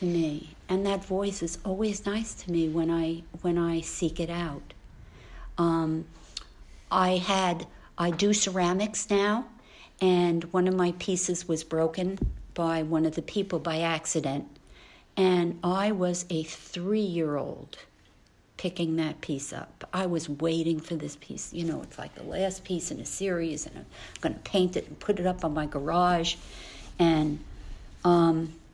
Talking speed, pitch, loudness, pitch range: 165 wpm, 170 Hz, -29 LUFS, 160-185 Hz